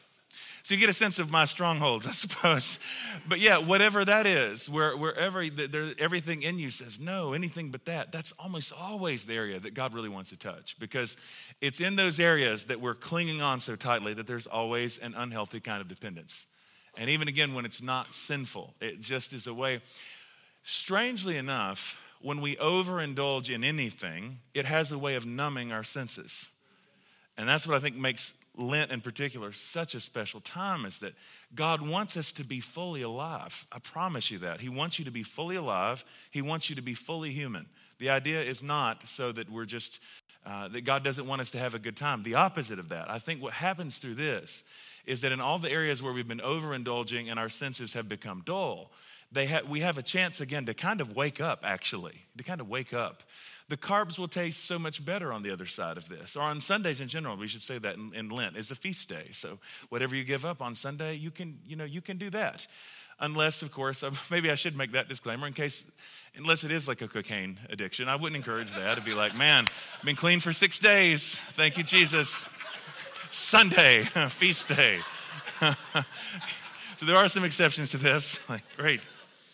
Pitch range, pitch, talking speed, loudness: 120-165 Hz, 145 Hz, 210 wpm, -29 LUFS